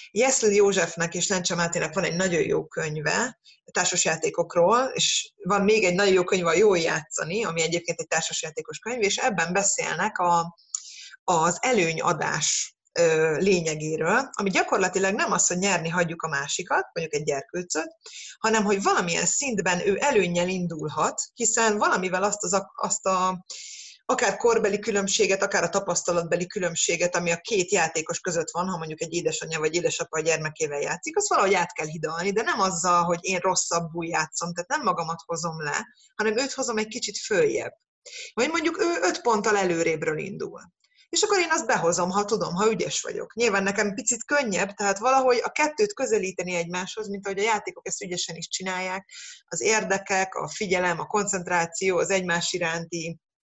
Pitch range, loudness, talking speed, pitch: 170-220 Hz, -24 LUFS, 165 wpm, 190 Hz